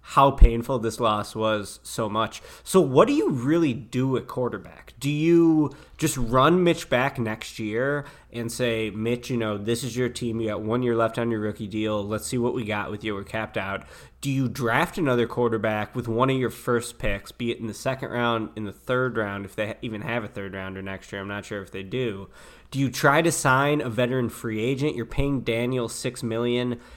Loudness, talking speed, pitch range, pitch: -25 LUFS, 225 wpm, 110-130 Hz, 120 Hz